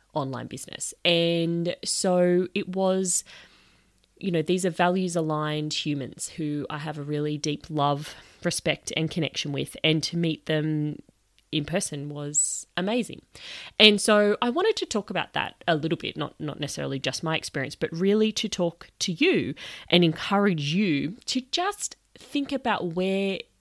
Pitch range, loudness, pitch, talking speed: 150-190 Hz, -26 LUFS, 170 Hz, 160 wpm